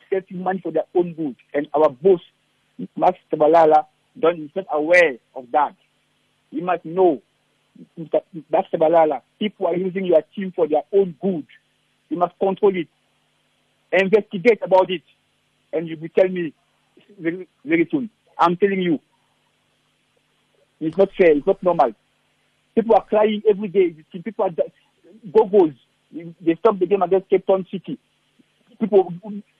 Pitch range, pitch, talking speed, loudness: 165-205 Hz, 185 Hz, 145 wpm, -20 LUFS